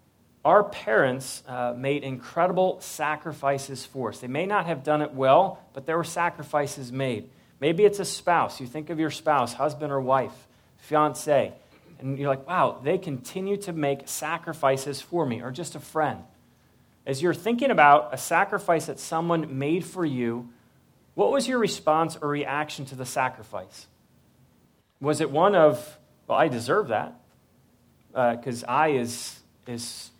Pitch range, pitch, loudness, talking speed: 130-165 Hz, 145 Hz, -25 LUFS, 160 wpm